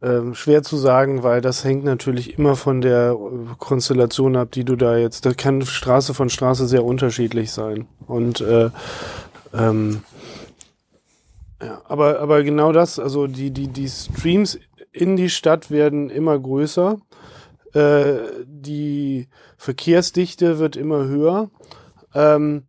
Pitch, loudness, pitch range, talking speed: 135 Hz, -18 LUFS, 125-150 Hz, 135 wpm